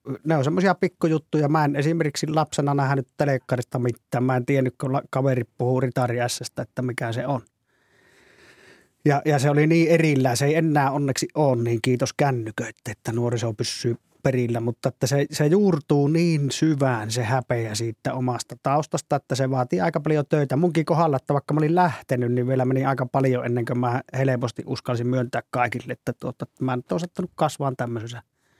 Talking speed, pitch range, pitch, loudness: 180 wpm, 125-150 Hz, 135 Hz, -23 LUFS